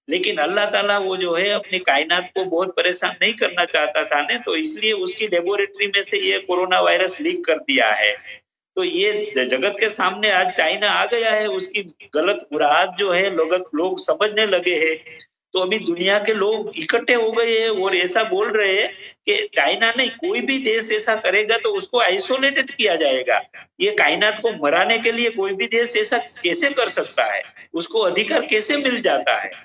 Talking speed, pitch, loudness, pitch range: 205 wpm, 215 Hz, -19 LUFS, 185-260 Hz